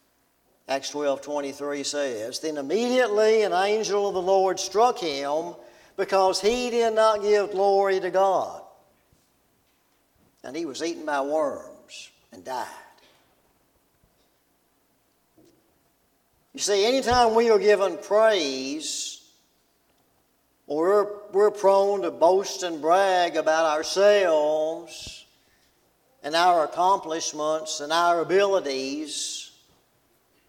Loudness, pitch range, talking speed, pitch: -23 LUFS, 155-210 Hz, 105 wpm, 190 Hz